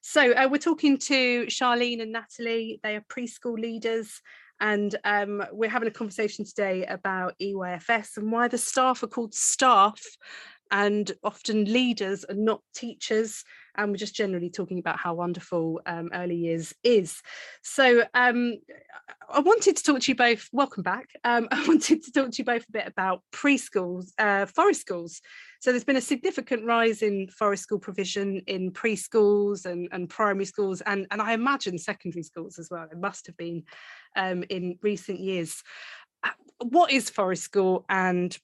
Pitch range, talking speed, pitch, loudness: 190-245 Hz, 170 wpm, 215 Hz, -26 LUFS